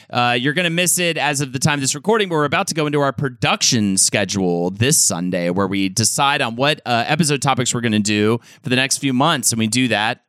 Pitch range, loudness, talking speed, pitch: 110-150 Hz, -17 LUFS, 265 wpm, 135 Hz